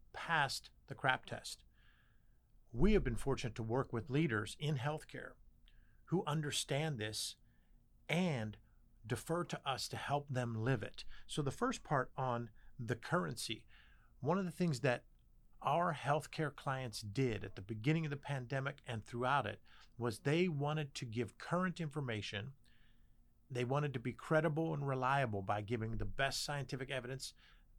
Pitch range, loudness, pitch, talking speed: 115-150 Hz, -39 LUFS, 130 Hz, 155 wpm